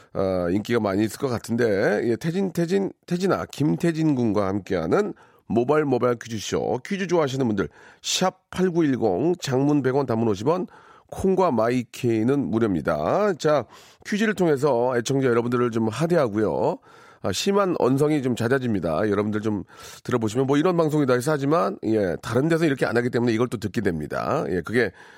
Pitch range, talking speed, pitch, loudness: 115-170 Hz, 345 characters per minute, 130 Hz, -23 LUFS